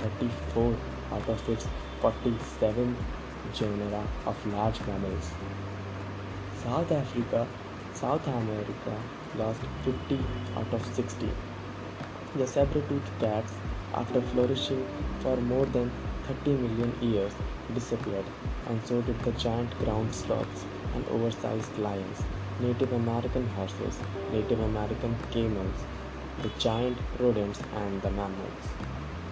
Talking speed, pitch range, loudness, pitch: 105 wpm, 100-120 Hz, -32 LUFS, 110 Hz